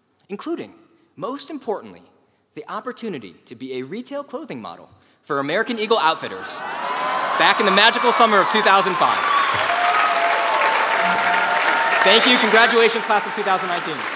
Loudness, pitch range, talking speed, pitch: -17 LUFS, 190-250 Hz, 120 wpm, 225 Hz